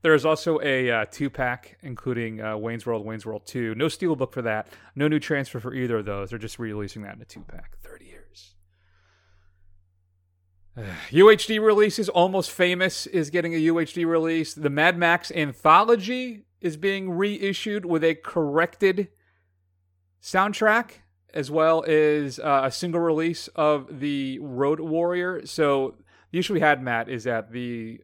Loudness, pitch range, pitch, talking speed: -23 LUFS, 110-170 Hz, 145 Hz, 165 wpm